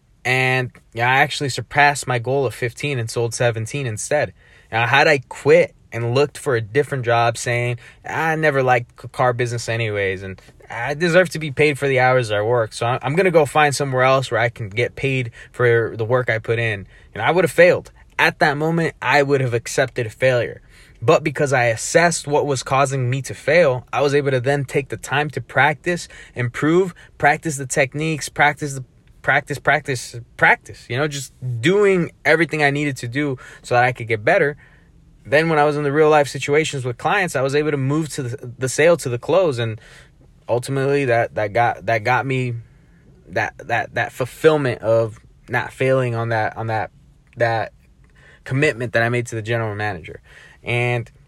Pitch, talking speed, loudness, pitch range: 130 Hz, 200 wpm, -19 LUFS, 120-145 Hz